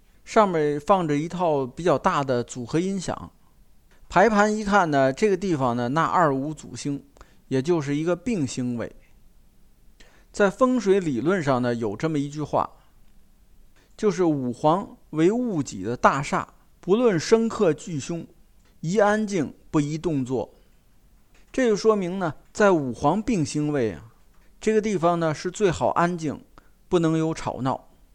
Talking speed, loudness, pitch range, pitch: 215 characters per minute, -23 LUFS, 140-200 Hz, 165 Hz